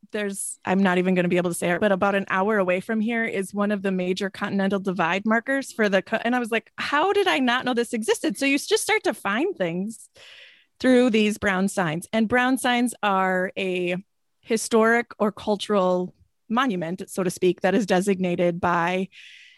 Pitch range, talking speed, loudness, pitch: 185-240 Hz, 205 wpm, -23 LUFS, 205 Hz